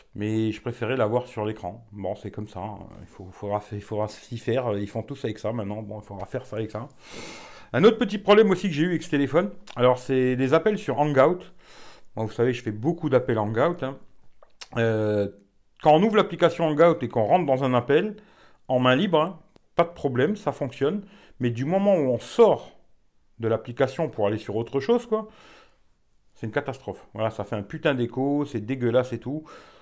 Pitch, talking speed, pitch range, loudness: 125 Hz, 215 wpm, 110-160 Hz, -24 LUFS